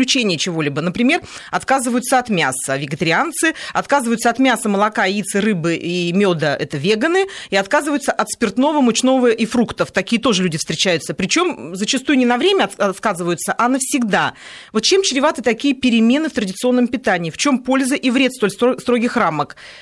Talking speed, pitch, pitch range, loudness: 155 wpm, 230 Hz, 190-265 Hz, -17 LUFS